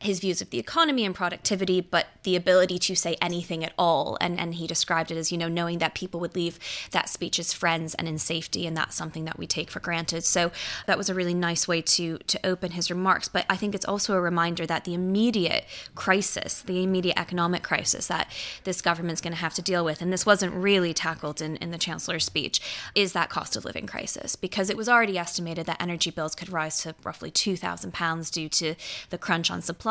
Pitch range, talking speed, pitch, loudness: 165-185 Hz, 230 wpm, 175 Hz, -26 LUFS